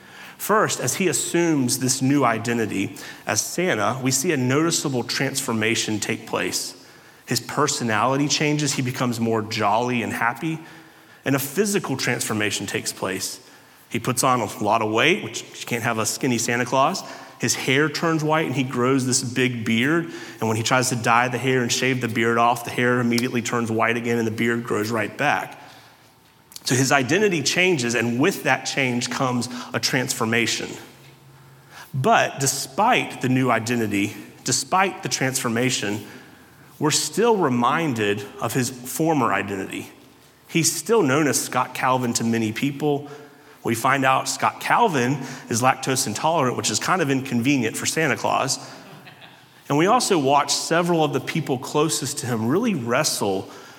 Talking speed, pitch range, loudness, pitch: 160 wpm, 115-145 Hz, -21 LUFS, 130 Hz